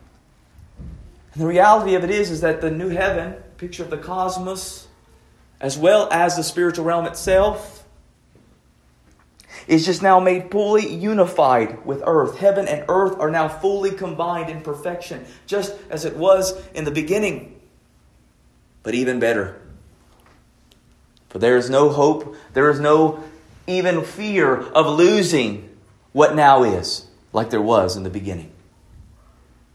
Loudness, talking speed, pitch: -19 LUFS, 140 wpm, 160 Hz